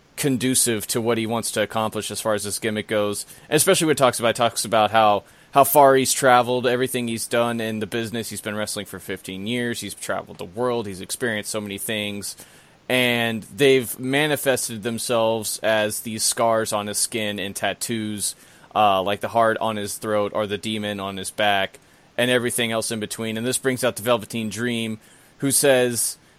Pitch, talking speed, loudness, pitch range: 110 Hz, 200 wpm, -22 LUFS, 105-125 Hz